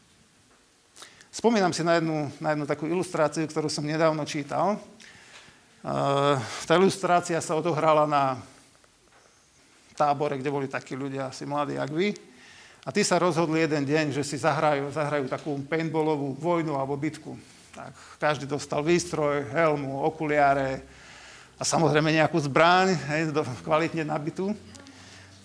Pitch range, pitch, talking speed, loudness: 145-165 Hz, 155 Hz, 130 wpm, -26 LUFS